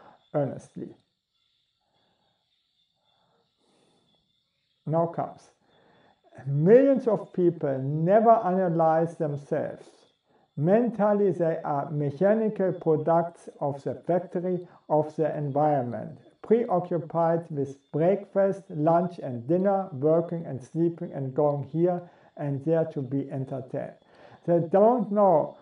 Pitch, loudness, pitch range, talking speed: 165 Hz, -26 LUFS, 145-185 Hz, 95 wpm